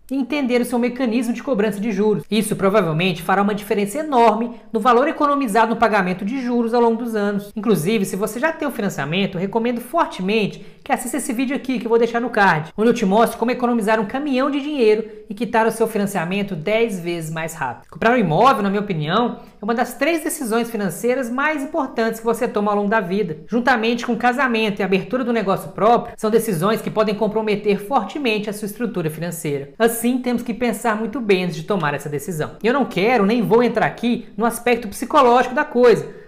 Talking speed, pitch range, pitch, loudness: 210 wpm, 205-245 Hz, 225 Hz, -19 LUFS